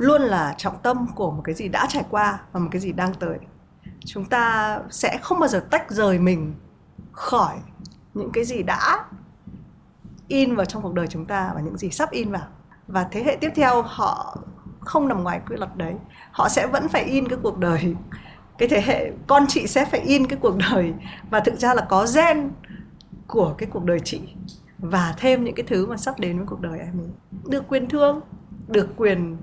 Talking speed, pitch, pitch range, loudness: 210 wpm, 200 Hz, 180-255 Hz, -22 LUFS